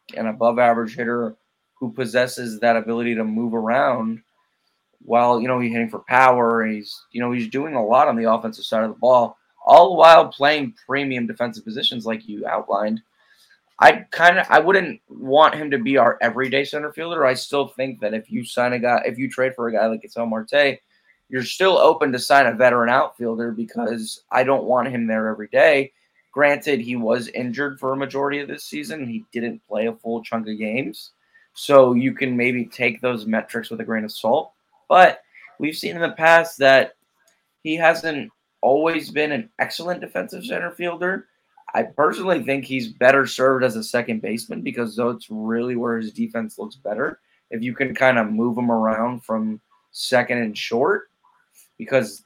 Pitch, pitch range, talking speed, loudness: 120 Hz, 115-140 Hz, 190 wpm, -19 LUFS